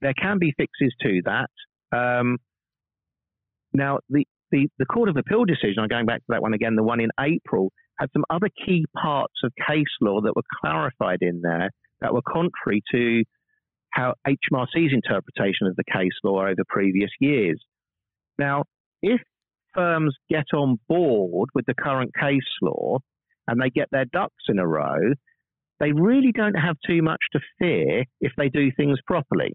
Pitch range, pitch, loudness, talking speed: 115-160 Hz, 140 Hz, -23 LUFS, 175 wpm